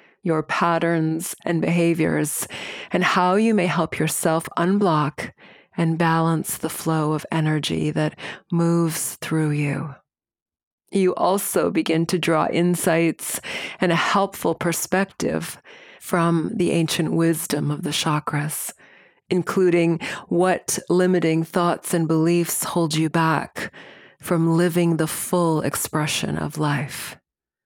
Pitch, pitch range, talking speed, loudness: 165 Hz, 155-175 Hz, 115 wpm, -21 LUFS